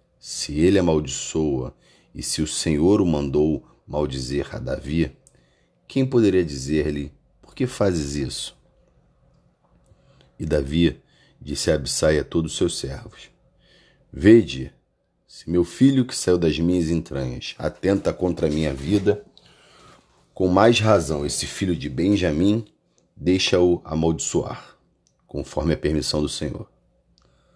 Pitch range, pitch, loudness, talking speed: 75-95 Hz, 80 Hz, -22 LUFS, 125 wpm